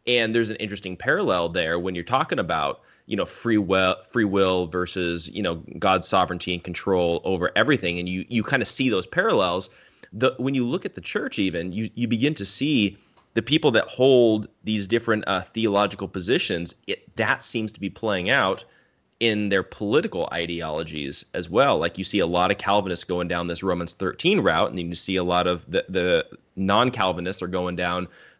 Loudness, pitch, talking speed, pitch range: -23 LUFS, 95 Hz, 200 wpm, 90-110 Hz